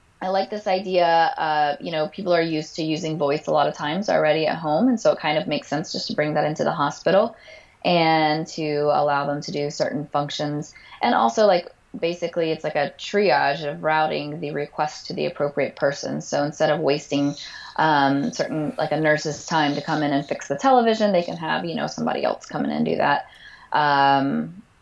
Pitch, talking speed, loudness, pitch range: 155 Hz, 215 wpm, -22 LUFS, 145-170 Hz